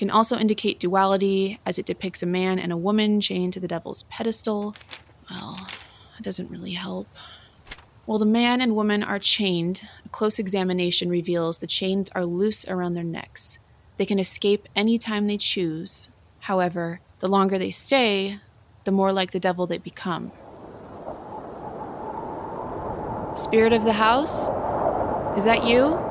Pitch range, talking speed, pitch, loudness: 180-215 Hz, 150 wpm, 195 Hz, -23 LUFS